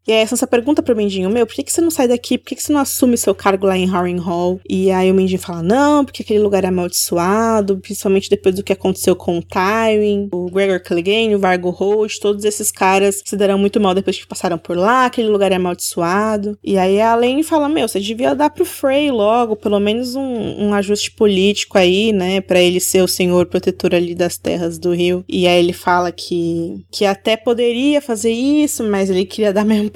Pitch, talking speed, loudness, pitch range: 200 Hz, 225 wpm, -16 LUFS, 185-225 Hz